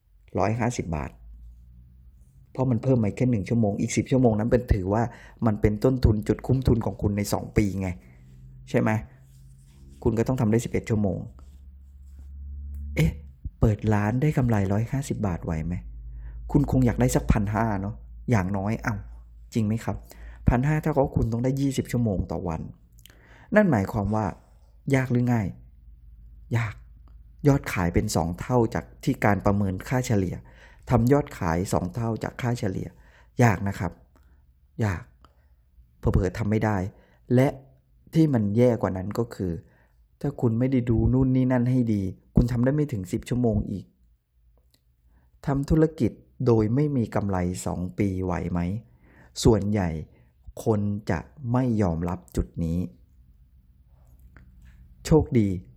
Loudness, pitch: -25 LUFS, 100 Hz